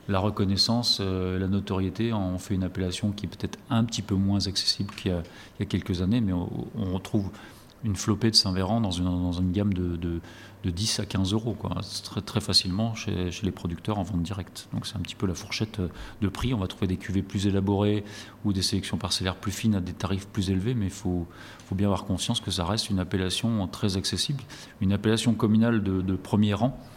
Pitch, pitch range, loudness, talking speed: 100 Hz, 95-110 Hz, -27 LUFS, 225 wpm